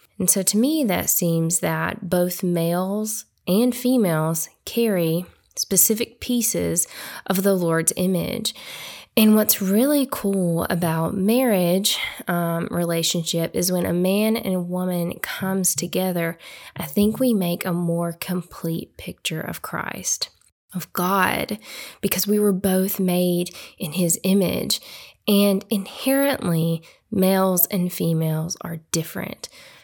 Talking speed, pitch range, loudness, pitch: 125 wpm, 170-205 Hz, -21 LUFS, 185 Hz